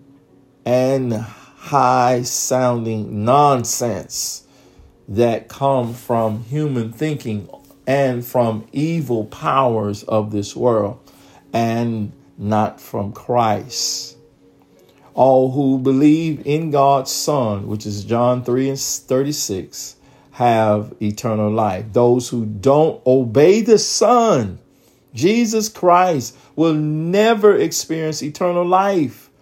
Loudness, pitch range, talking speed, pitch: -17 LUFS, 110-145 Hz, 95 wpm, 125 Hz